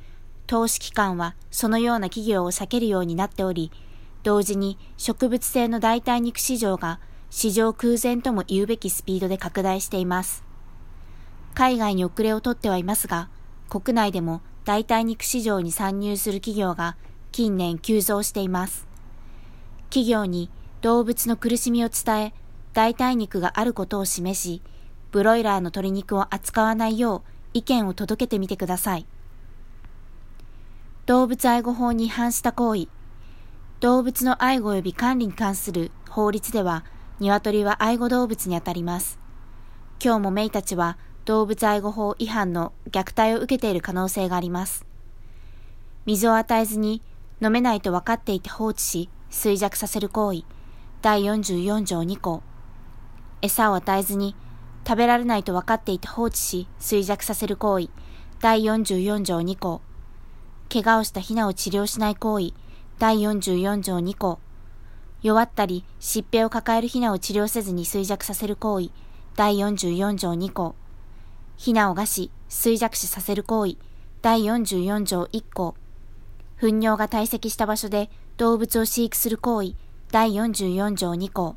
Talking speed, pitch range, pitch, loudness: 270 characters per minute, 180-225 Hz, 205 Hz, -23 LUFS